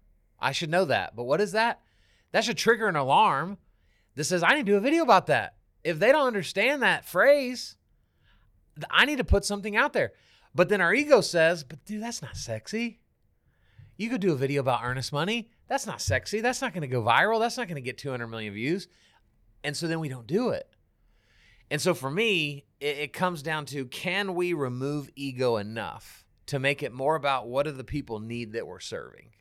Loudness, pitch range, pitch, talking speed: -26 LUFS, 125-205 Hz, 150 Hz, 215 wpm